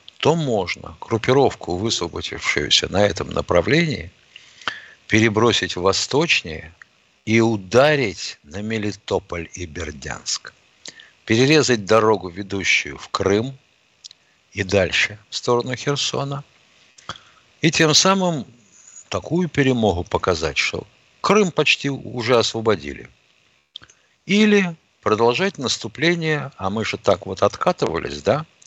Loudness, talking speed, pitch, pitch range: -19 LUFS, 100 wpm, 115 Hz, 100-145 Hz